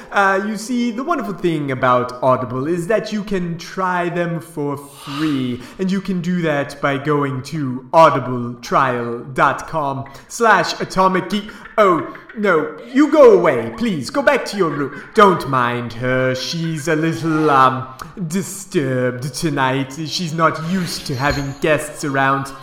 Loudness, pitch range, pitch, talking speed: -17 LUFS, 135-190 Hz, 160 Hz, 140 wpm